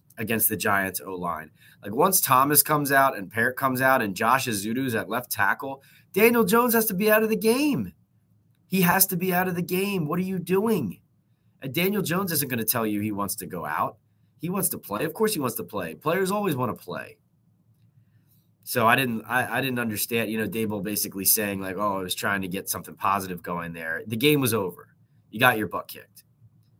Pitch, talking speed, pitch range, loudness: 130 Hz, 225 wpm, 110-180 Hz, -24 LUFS